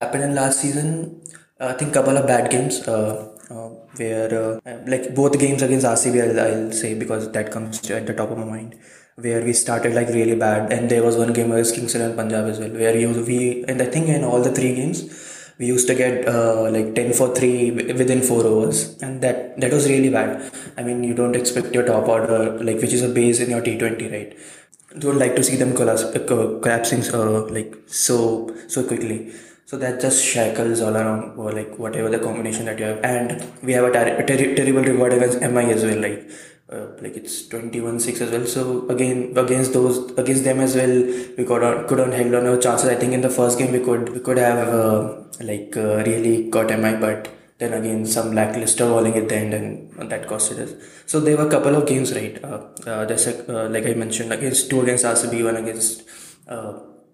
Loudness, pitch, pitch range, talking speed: -19 LUFS, 120 Hz, 110-125 Hz, 220 wpm